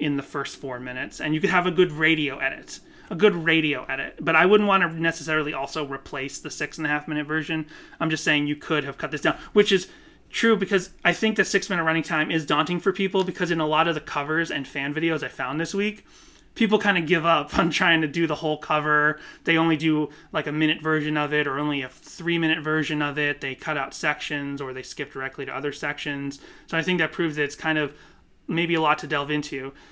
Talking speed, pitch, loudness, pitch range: 250 wpm, 155 Hz, -24 LUFS, 150-170 Hz